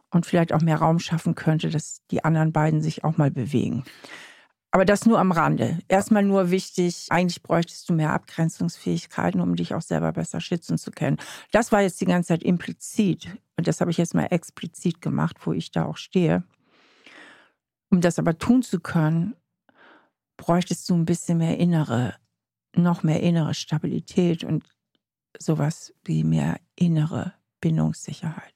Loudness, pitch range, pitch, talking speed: -24 LUFS, 155-180 Hz, 170 Hz, 165 wpm